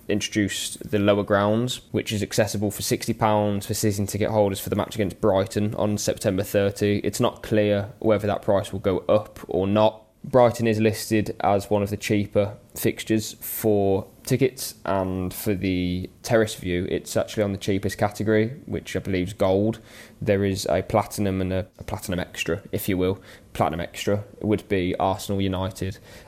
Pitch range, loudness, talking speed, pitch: 95-110 Hz, -24 LUFS, 175 wpm, 105 Hz